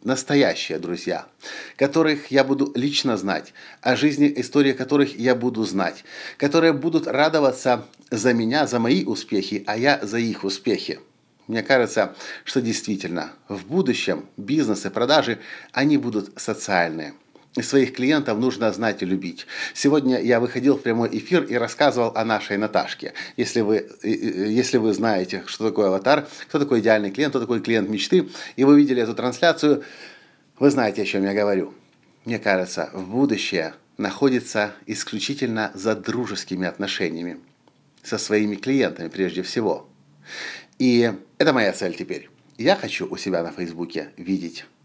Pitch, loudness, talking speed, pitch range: 120 Hz, -22 LUFS, 145 wpm, 100-135 Hz